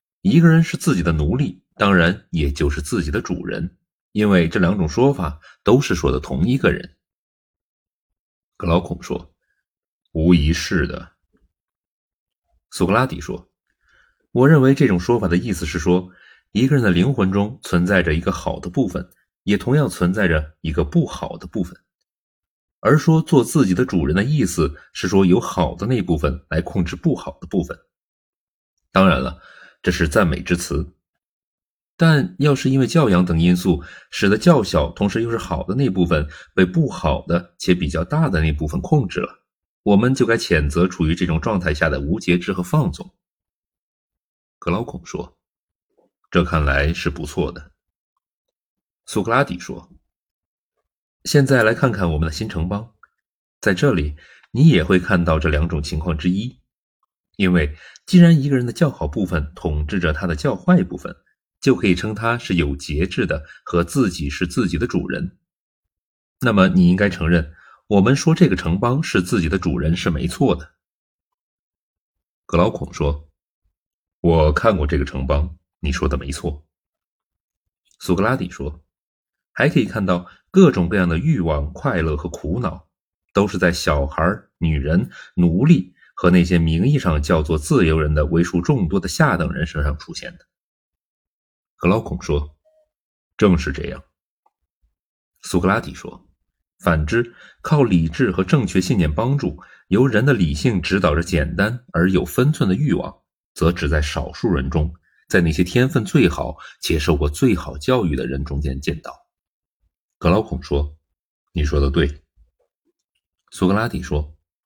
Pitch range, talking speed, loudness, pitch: 80-100 Hz, 230 characters per minute, -19 LUFS, 90 Hz